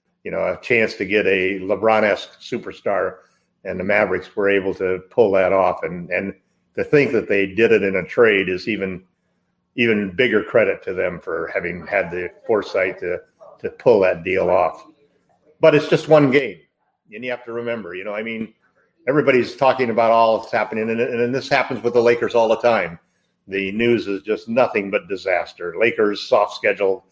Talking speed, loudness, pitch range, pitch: 195 wpm, -19 LUFS, 105-165 Hz, 120 Hz